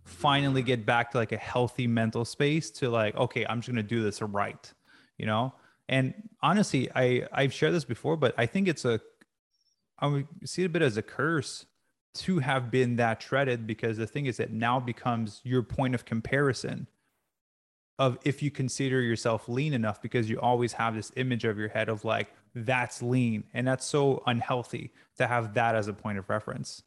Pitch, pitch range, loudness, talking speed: 120 Hz, 115-130 Hz, -29 LUFS, 200 wpm